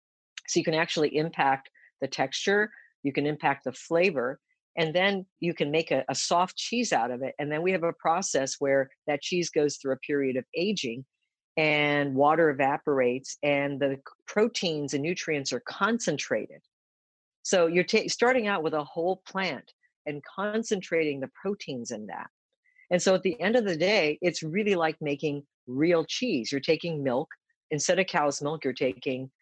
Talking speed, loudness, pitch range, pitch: 175 wpm, -27 LUFS, 140-185 Hz, 160 Hz